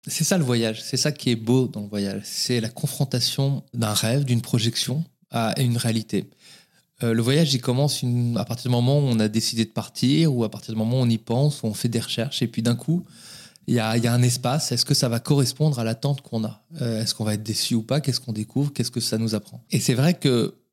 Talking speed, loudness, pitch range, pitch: 265 wpm, -23 LUFS, 115-140 Hz, 120 Hz